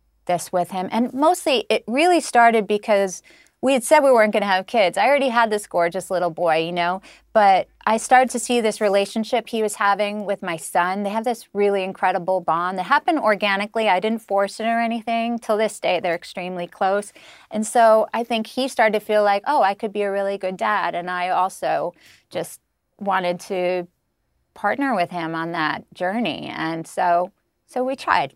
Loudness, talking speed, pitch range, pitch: -20 LUFS, 200 wpm, 185-230 Hz, 205 Hz